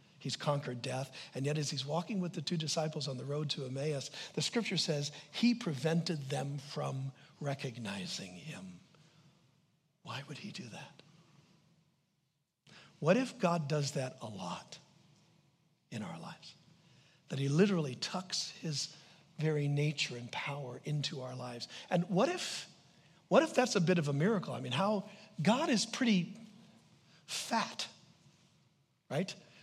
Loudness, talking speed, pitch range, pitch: -36 LUFS, 145 wpm, 145-180 Hz, 160 Hz